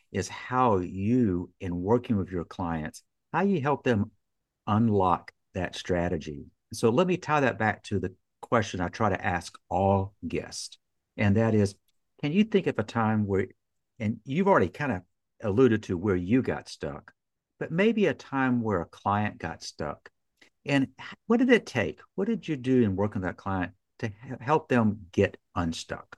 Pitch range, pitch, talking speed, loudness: 95-130 Hz, 105 Hz, 180 wpm, -28 LUFS